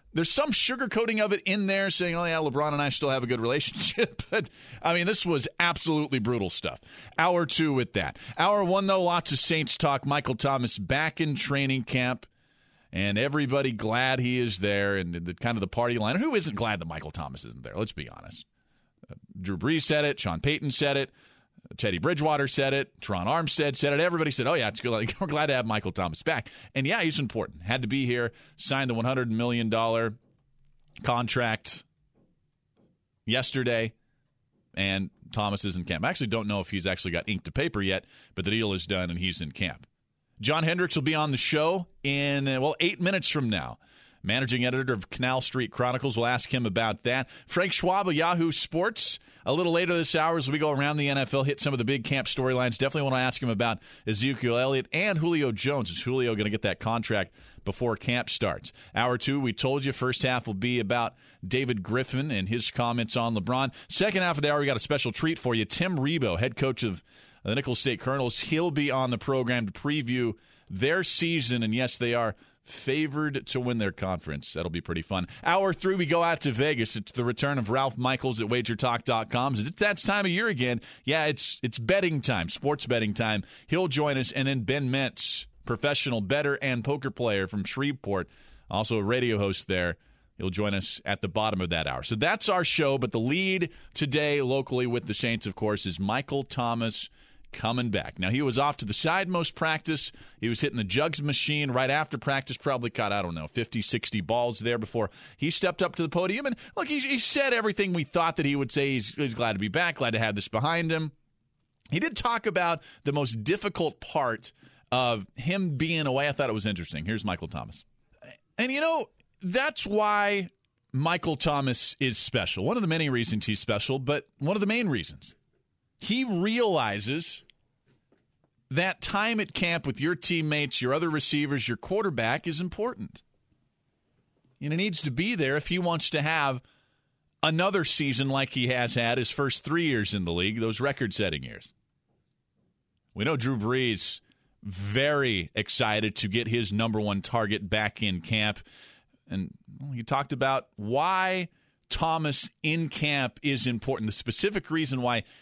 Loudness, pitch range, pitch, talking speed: -28 LUFS, 115-155 Hz, 130 Hz, 200 wpm